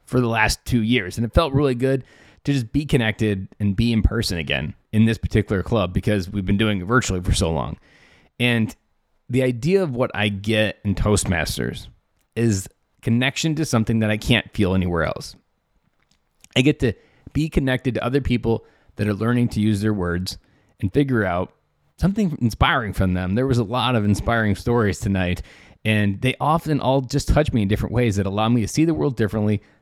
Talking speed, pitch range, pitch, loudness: 200 wpm, 100-130 Hz, 110 Hz, -21 LUFS